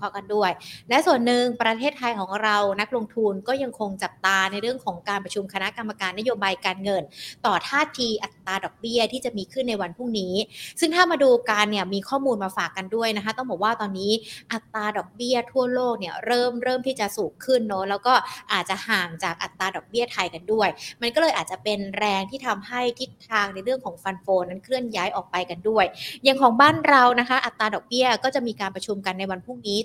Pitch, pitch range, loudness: 215 Hz, 195-250 Hz, -23 LUFS